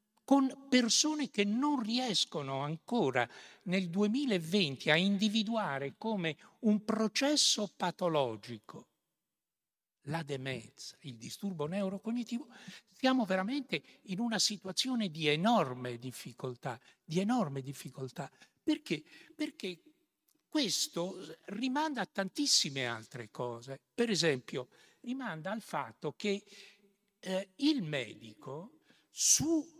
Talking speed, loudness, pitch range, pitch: 95 wpm, -33 LUFS, 155-245 Hz, 200 Hz